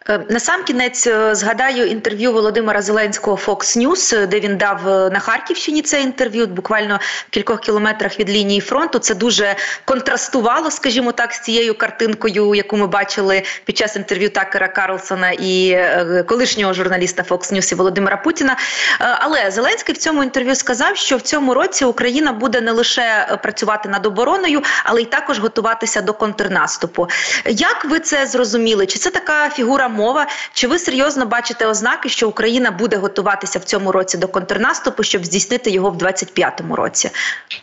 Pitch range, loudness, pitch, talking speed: 200-260 Hz, -16 LUFS, 225 Hz, 155 wpm